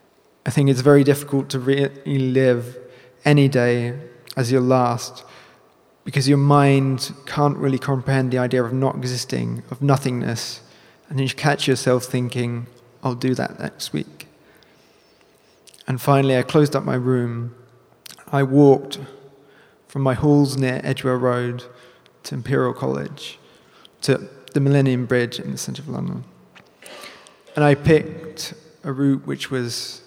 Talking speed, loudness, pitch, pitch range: 140 wpm, -20 LUFS, 130 Hz, 125-140 Hz